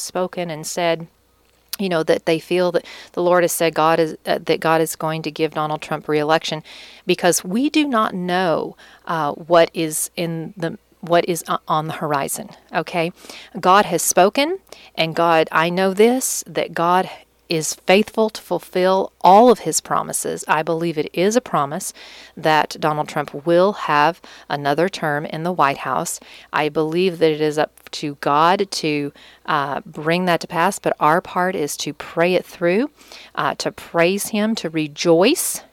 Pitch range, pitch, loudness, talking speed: 160-185 Hz, 170 Hz, -19 LUFS, 175 wpm